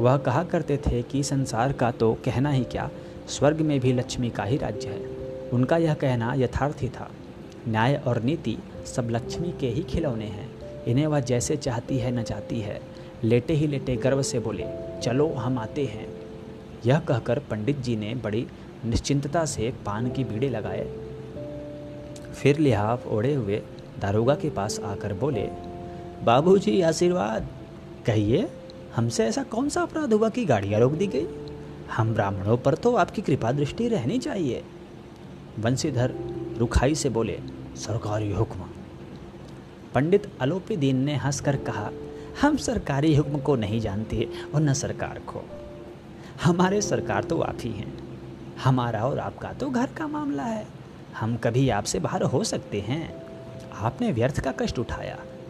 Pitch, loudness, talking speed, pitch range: 130 Hz, -26 LUFS, 155 wpm, 110-150 Hz